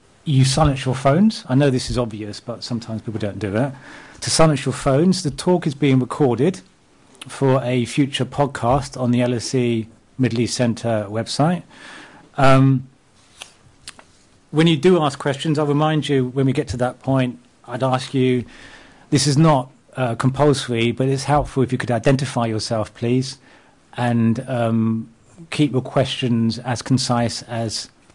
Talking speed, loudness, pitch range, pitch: 170 wpm, -19 LUFS, 120-145 Hz, 130 Hz